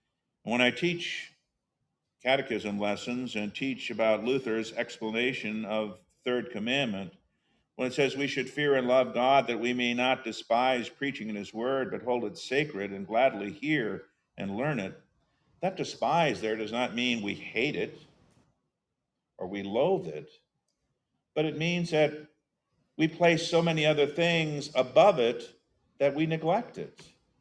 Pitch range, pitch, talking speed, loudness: 110-145 Hz, 125 Hz, 155 wpm, -29 LUFS